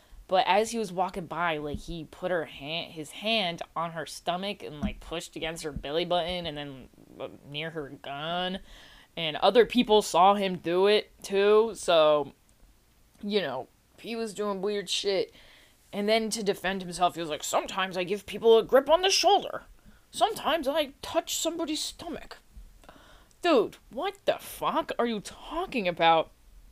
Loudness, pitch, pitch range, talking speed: -27 LUFS, 185 Hz, 160-225 Hz, 165 wpm